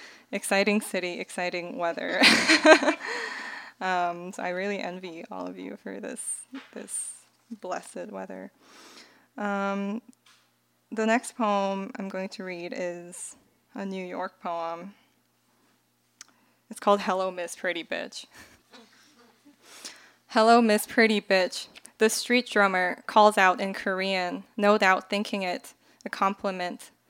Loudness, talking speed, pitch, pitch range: -25 LUFS, 115 wpm, 200 Hz, 185-230 Hz